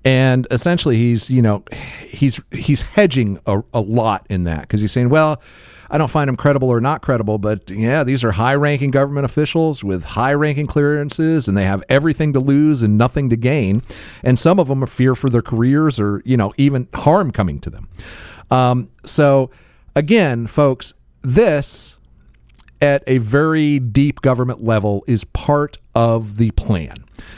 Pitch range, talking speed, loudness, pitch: 110-145 Hz, 175 wpm, -16 LUFS, 125 Hz